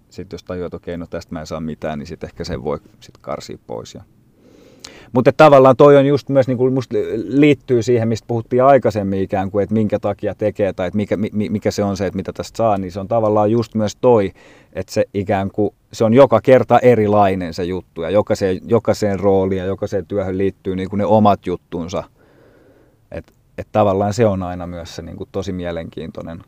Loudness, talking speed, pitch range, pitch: -16 LUFS, 200 wpm, 95-115 Hz, 105 Hz